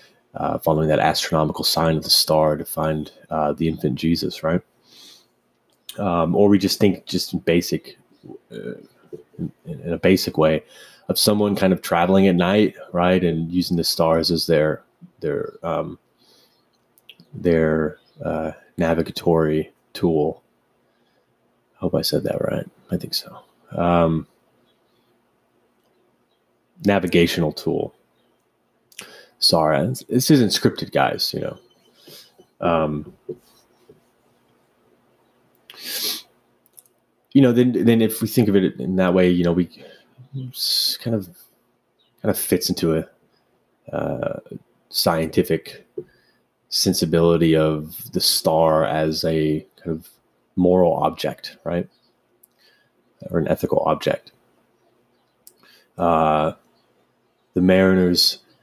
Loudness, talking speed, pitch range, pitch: -20 LUFS, 115 wpm, 80-95 Hz, 85 Hz